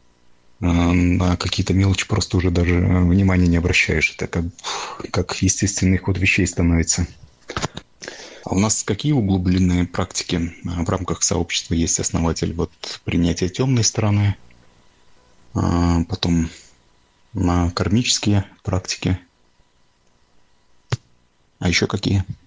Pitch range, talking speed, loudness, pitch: 85-95 Hz, 105 wpm, -20 LUFS, 90 Hz